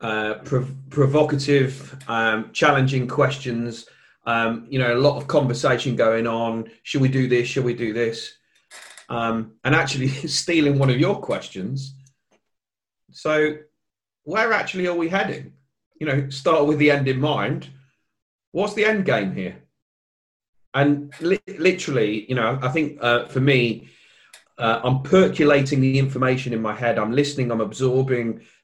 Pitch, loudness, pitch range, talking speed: 135 Hz, -21 LUFS, 120-150 Hz, 150 wpm